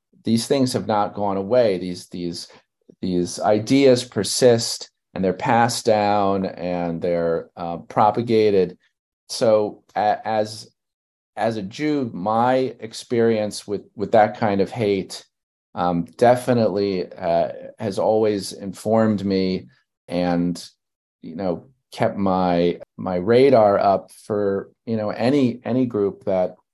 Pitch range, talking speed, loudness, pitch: 90-115 Hz, 120 wpm, -21 LUFS, 105 Hz